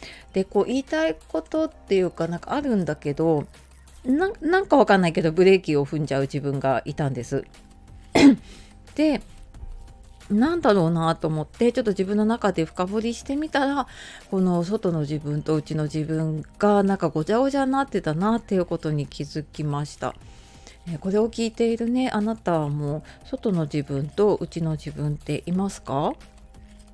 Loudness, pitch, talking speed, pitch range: -24 LUFS, 170 Hz, 340 characters per minute, 150-220 Hz